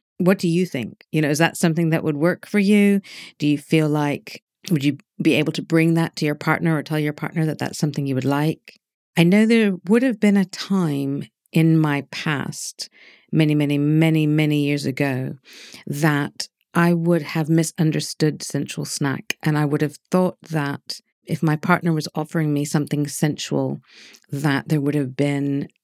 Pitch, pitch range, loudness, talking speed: 155 Hz, 145-175 Hz, -21 LUFS, 190 wpm